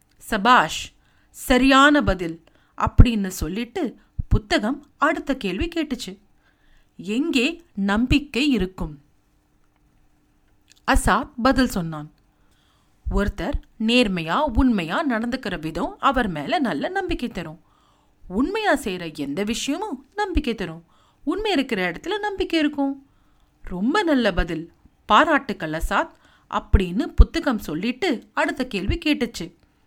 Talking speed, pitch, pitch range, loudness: 95 wpm, 250 Hz, 190-295 Hz, -22 LUFS